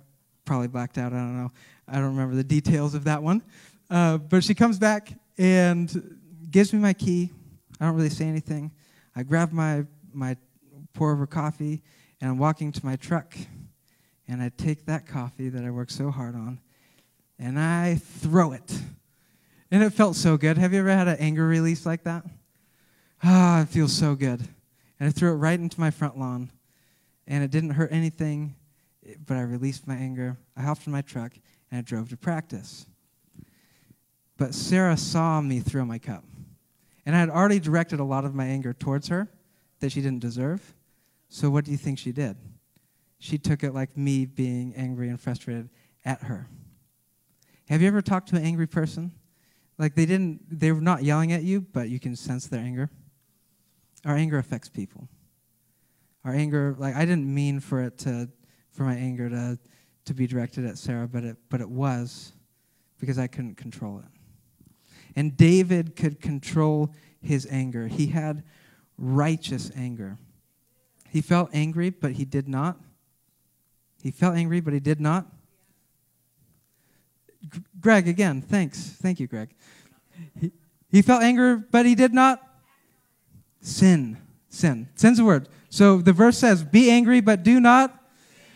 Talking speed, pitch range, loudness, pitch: 170 wpm, 130-170 Hz, -24 LUFS, 150 Hz